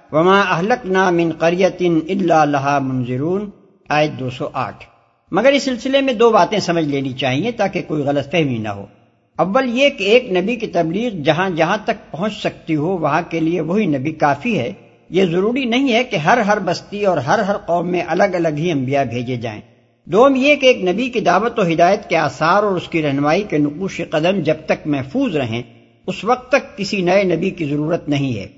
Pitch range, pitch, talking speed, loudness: 145-205 Hz, 175 Hz, 205 wpm, -17 LUFS